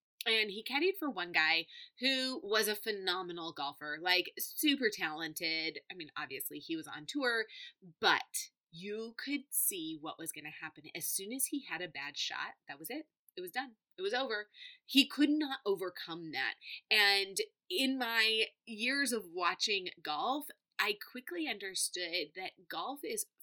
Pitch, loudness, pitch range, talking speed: 225 Hz, -34 LUFS, 180-295 Hz, 165 wpm